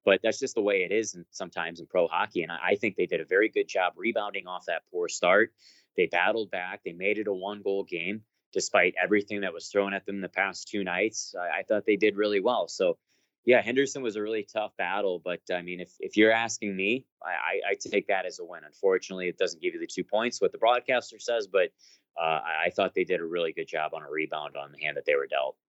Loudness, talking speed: -28 LUFS, 250 wpm